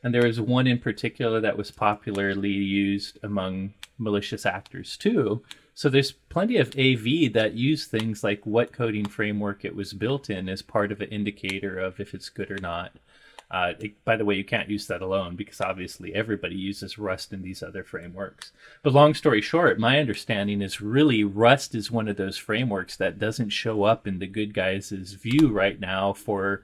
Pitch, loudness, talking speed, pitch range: 105 Hz, -25 LUFS, 195 wpm, 100-120 Hz